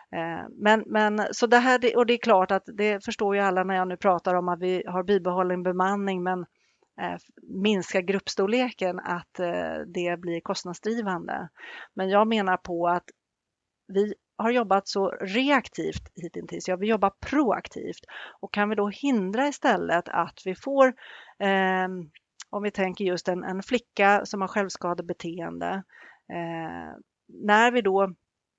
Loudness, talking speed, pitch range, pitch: -26 LUFS, 150 wpm, 185-220 Hz, 195 Hz